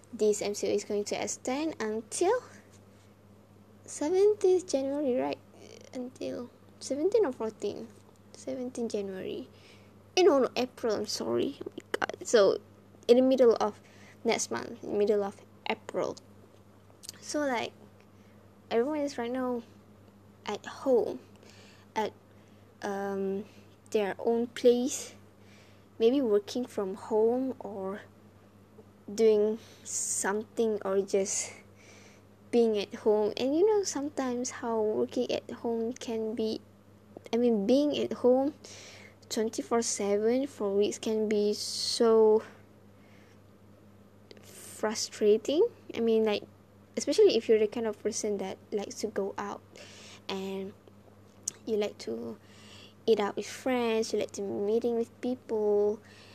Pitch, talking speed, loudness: 210 Hz, 120 wpm, -30 LUFS